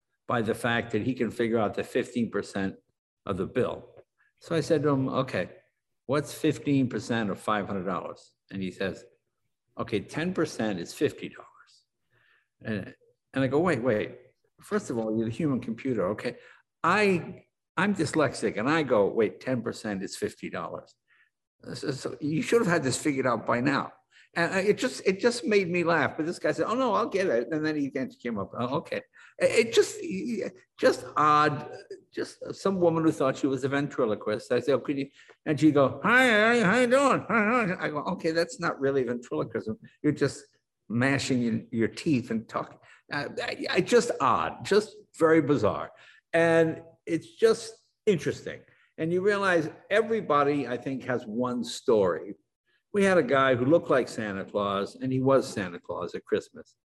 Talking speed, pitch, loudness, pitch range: 180 wpm, 155 Hz, -27 LUFS, 130-195 Hz